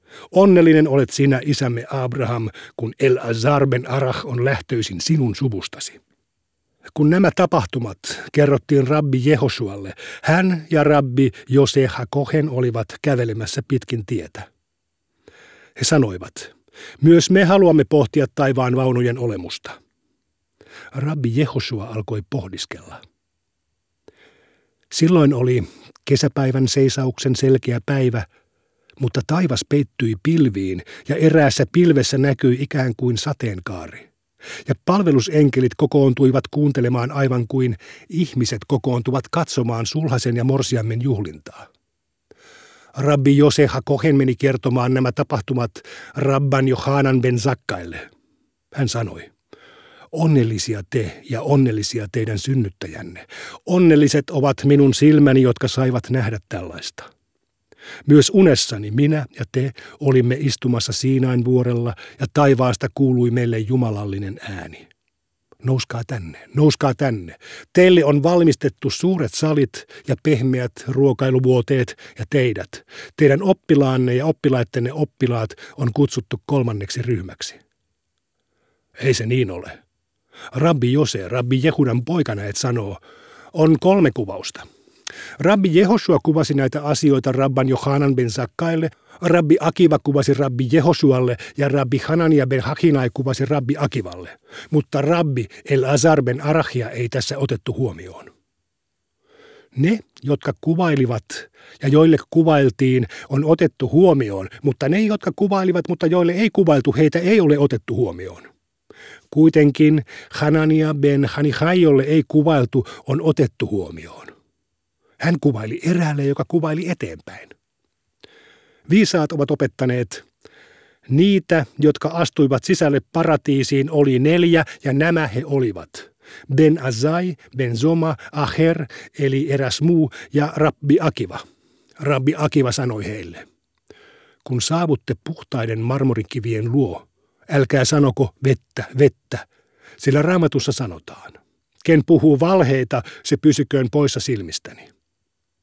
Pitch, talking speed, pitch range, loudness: 135 Hz, 110 wpm, 125-150 Hz, -18 LUFS